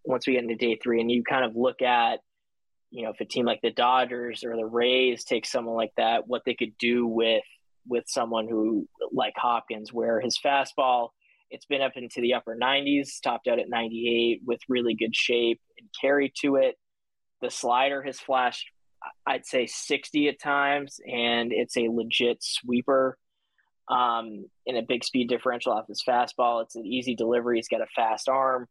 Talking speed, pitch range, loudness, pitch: 190 wpm, 115-130 Hz, -26 LUFS, 120 Hz